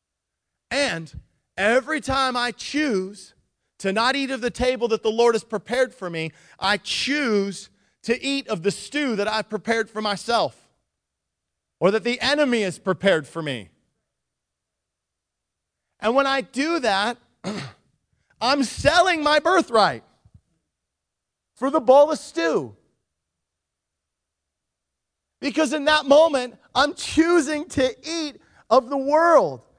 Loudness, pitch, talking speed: -21 LUFS, 230 Hz, 125 wpm